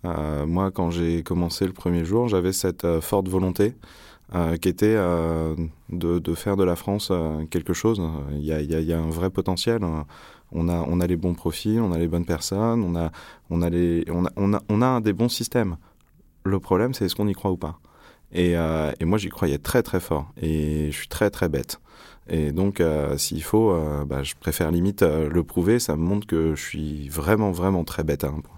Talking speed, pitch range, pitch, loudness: 240 wpm, 80-95 Hz, 85 Hz, -24 LUFS